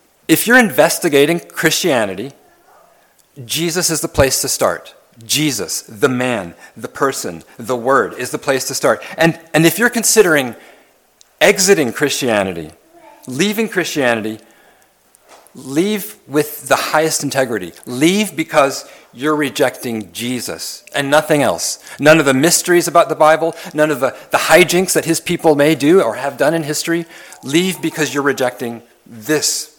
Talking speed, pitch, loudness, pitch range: 145 wpm, 155 Hz, -15 LUFS, 135-170 Hz